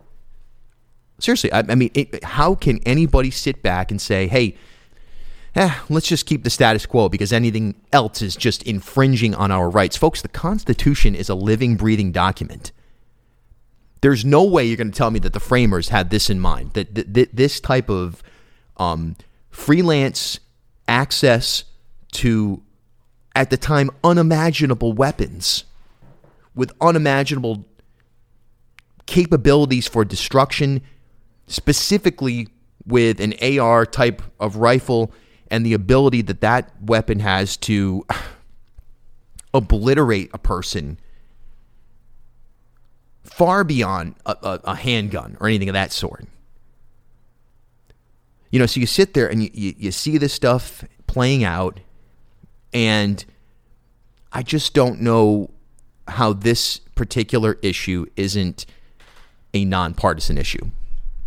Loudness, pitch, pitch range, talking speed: -18 LUFS, 115 Hz, 105-125 Hz, 125 wpm